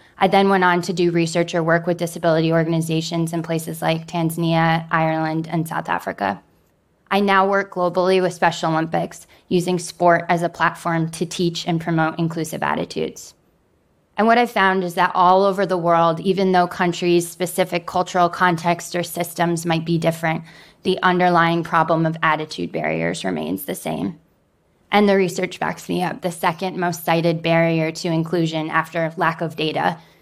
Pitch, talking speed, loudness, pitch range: 170 Hz, 170 wpm, -20 LUFS, 165-180 Hz